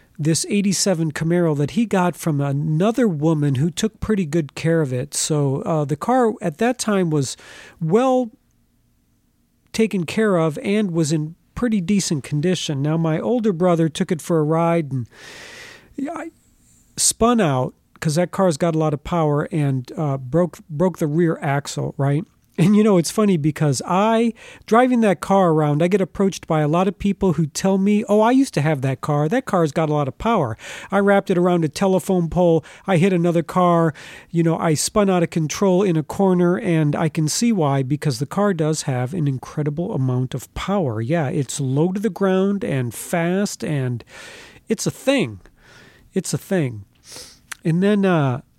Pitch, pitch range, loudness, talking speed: 170 Hz, 150-195 Hz, -20 LUFS, 190 wpm